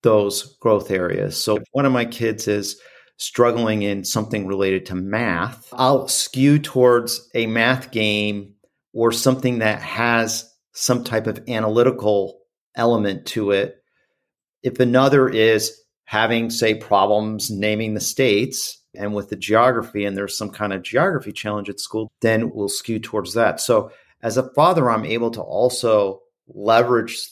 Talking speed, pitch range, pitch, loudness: 150 wpm, 105-120 Hz, 110 Hz, -20 LUFS